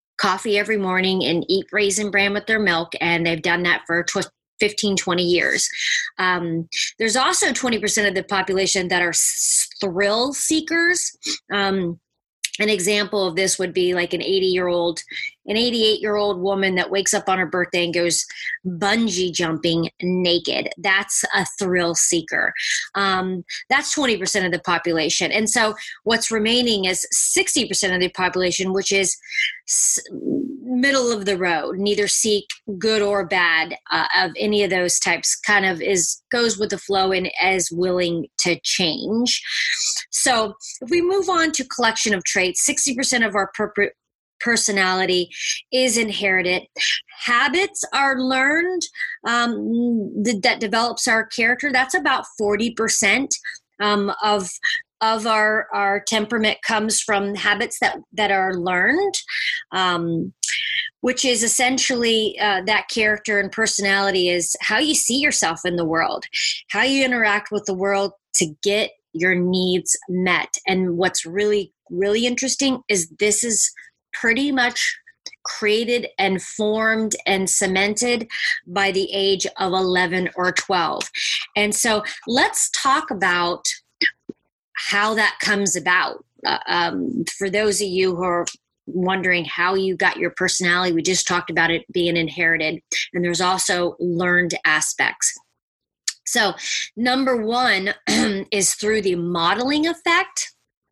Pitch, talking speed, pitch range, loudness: 205 Hz, 145 wpm, 185-235 Hz, -19 LUFS